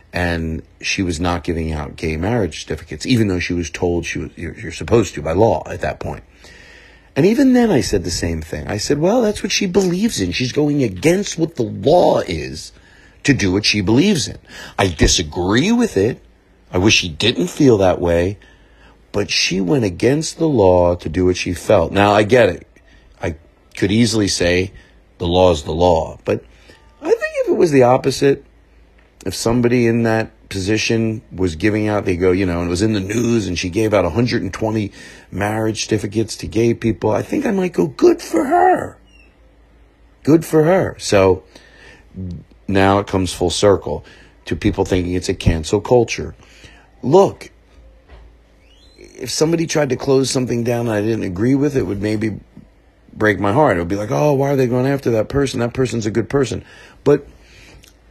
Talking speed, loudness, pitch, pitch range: 190 wpm, -17 LUFS, 105 Hz, 90-130 Hz